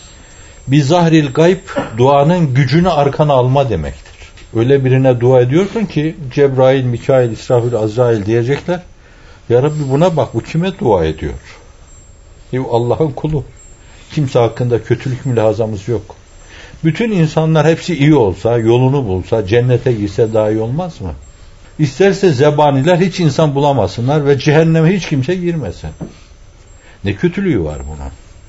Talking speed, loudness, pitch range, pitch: 125 wpm, -13 LUFS, 105-155 Hz, 130 Hz